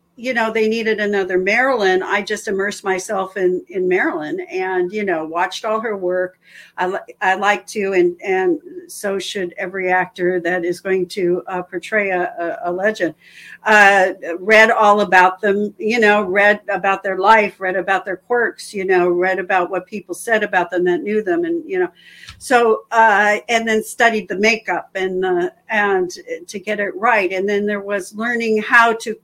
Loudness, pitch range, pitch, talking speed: -17 LUFS, 185-220 Hz, 205 Hz, 185 wpm